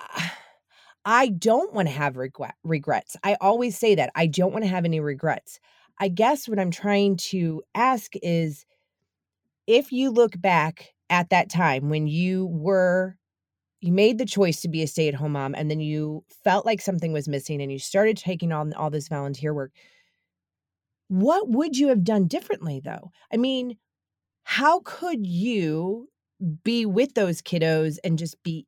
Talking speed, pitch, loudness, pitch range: 175 wpm, 180 Hz, -24 LUFS, 155-215 Hz